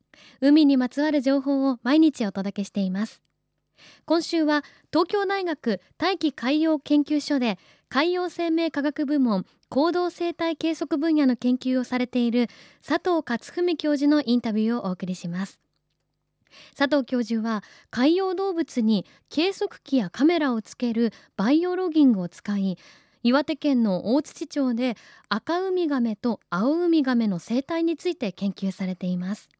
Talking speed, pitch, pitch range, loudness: 290 characters per minute, 275 Hz, 225-320 Hz, -24 LUFS